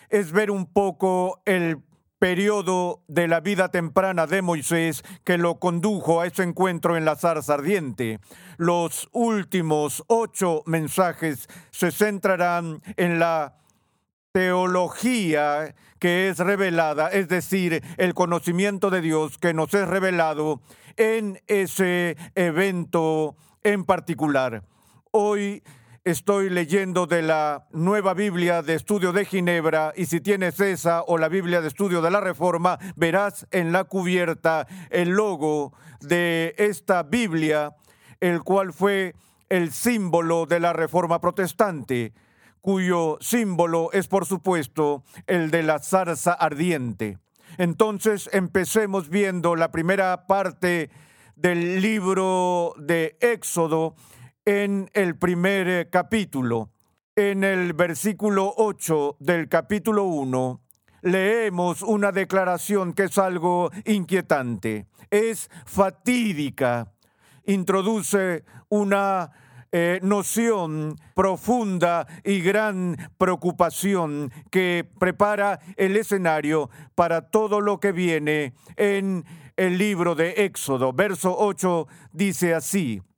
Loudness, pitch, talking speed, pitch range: -23 LUFS, 180 Hz, 115 wpm, 160-195 Hz